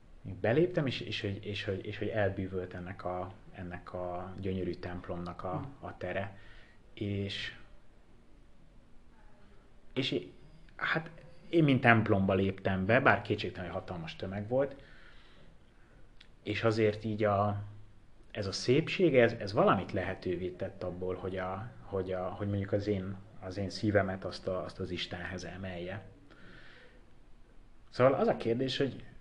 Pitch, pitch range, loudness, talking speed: 100 Hz, 90-110 Hz, -33 LUFS, 140 wpm